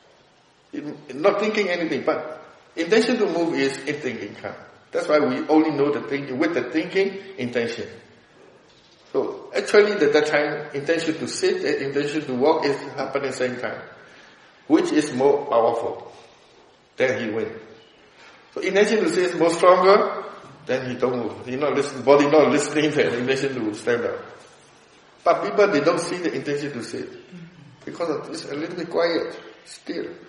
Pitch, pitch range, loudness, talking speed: 155 Hz, 140-205 Hz, -22 LUFS, 175 wpm